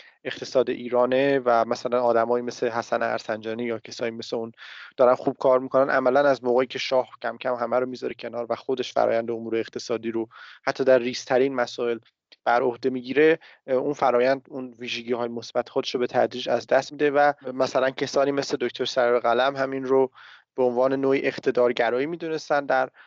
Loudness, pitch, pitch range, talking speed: -24 LUFS, 125 Hz, 120-135 Hz, 175 wpm